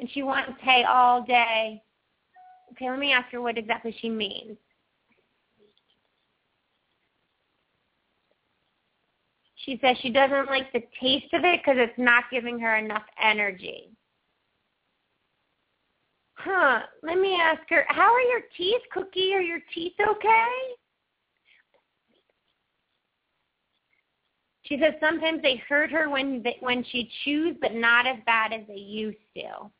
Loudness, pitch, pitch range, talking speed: -24 LUFS, 265 Hz, 235-335 Hz, 130 wpm